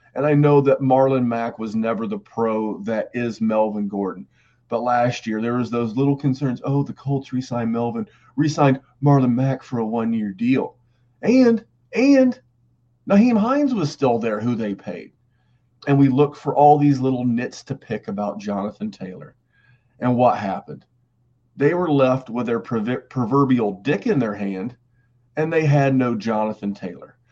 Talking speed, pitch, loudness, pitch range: 170 wpm, 125 Hz, -20 LUFS, 115-140 Hz